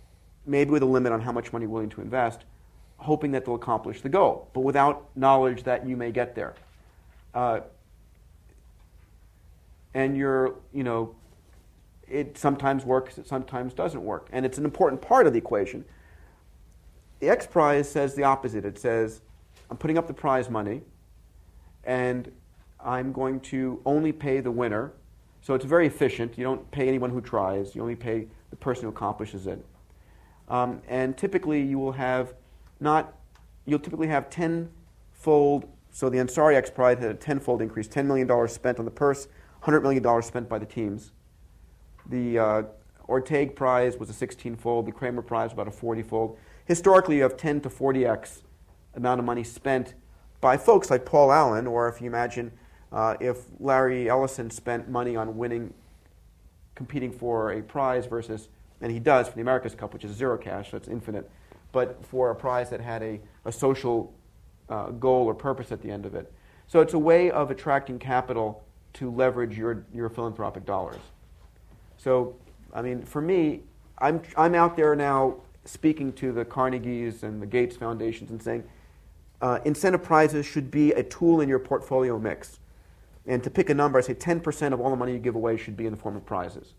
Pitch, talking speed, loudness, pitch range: 120 Hz, 185 wpm, -26 LUFS, 110-135 Hz